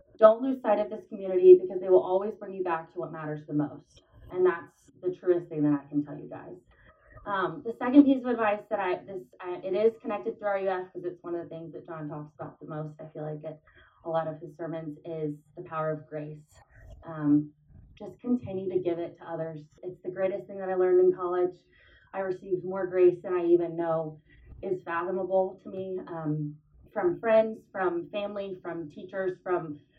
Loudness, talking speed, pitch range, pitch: -28 LUFS, 215 wpm, 160-195 Hz, 180 Hz